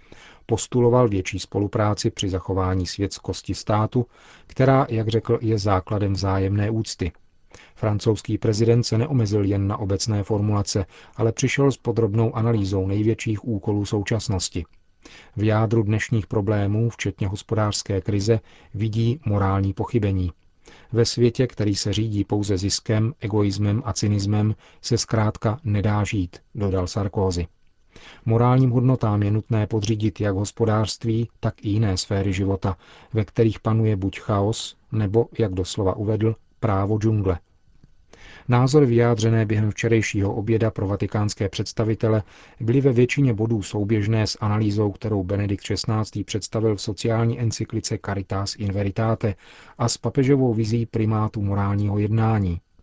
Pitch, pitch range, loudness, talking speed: 110 Hz, 100-115 Hz, -23 LUFS, 125 wpm